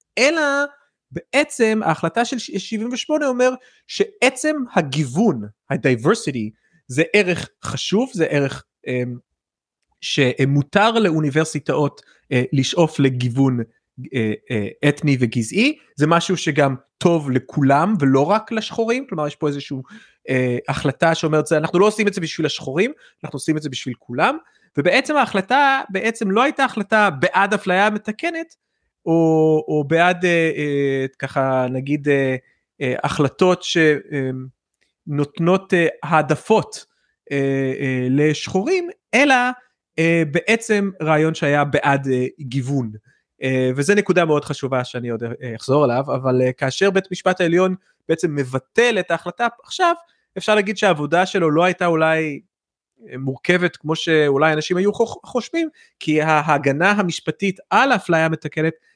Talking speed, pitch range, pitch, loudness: 115 wpm, 140-205 Hz, 160 Hz, -19 LUFS